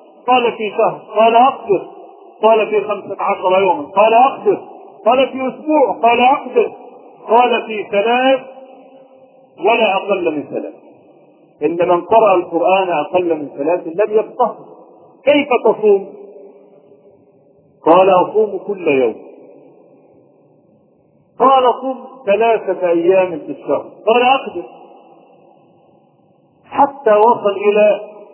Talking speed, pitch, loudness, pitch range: 105 wpm, 220 Hz, -14 LUFS, 190-260 Hz